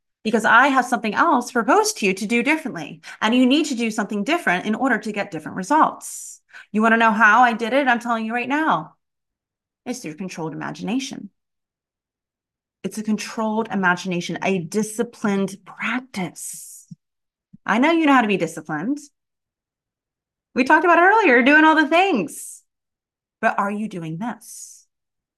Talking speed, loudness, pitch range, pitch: 165 wpm, -19 LUFS, 190-255 Hz, 225 Hz